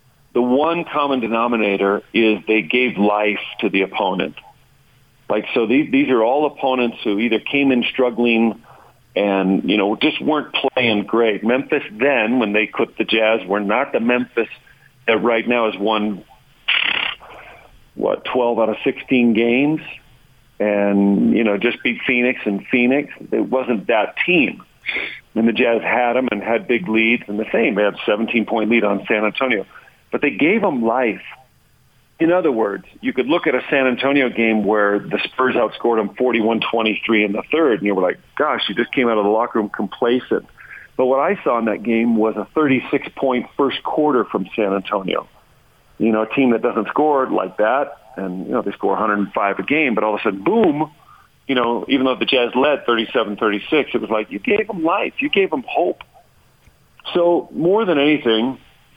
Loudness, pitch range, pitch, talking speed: -18 LUFS, 105-130 Hz, 115 Hz, 185 wpm